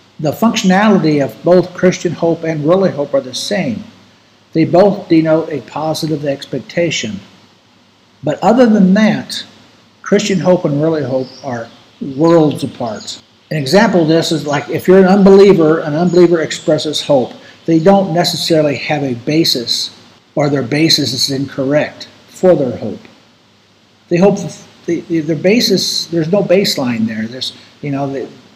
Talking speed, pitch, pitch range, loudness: 150 wpm, 165 Hz, 145-190 Hz, -13 LUFS